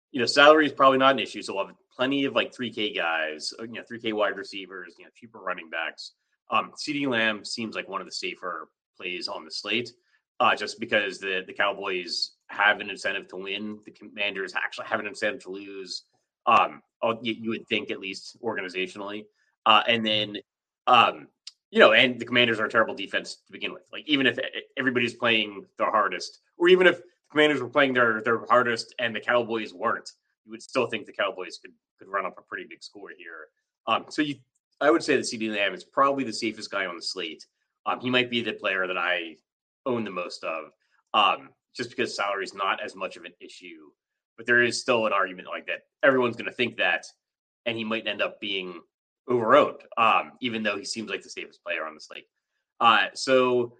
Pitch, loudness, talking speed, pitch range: 115 Hz, -25 LUFS, 210 wpm, 105-130 Hz